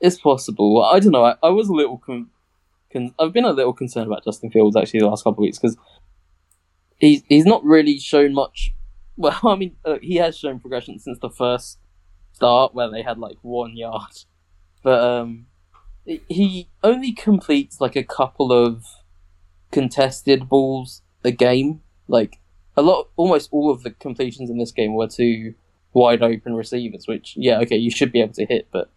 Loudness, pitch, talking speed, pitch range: -18 LUFS, 120 Hz, 190 wpm, 100-140 Hz